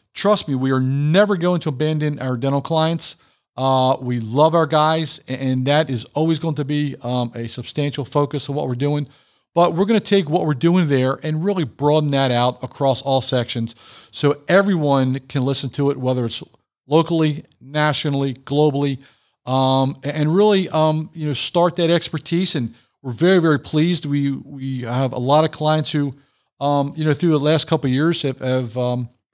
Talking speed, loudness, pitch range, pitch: 190 wpm, -19 LUFS, 130-160 Hz, 145 Hz